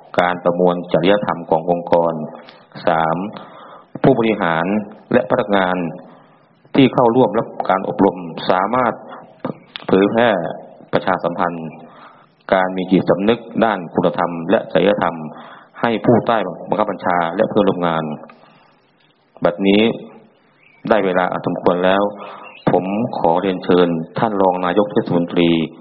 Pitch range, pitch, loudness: 85-100 Hz, 90 Hz, -17 LUFS